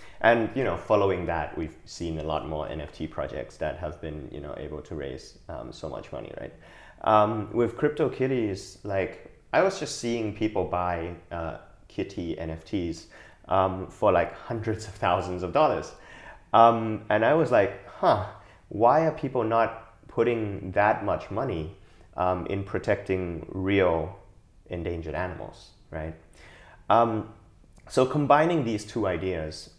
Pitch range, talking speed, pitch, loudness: 85-115 Hz, 150 wpm, 95 Hz, -27 LUFS